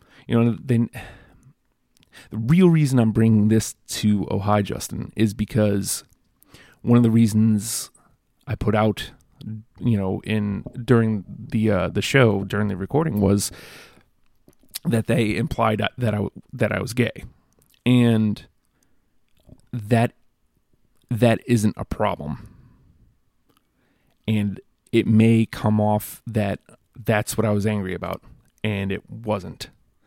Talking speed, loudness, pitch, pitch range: 130 wpm, -22 LUFS, 110 Hz, 105-115 Hz